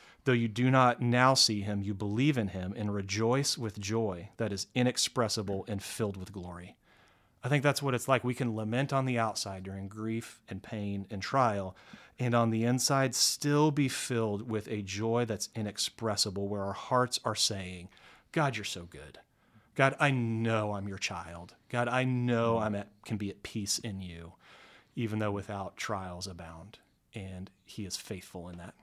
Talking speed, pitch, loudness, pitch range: 185 wpm, 110 Hz, -31 LUFS, 100-125 Hz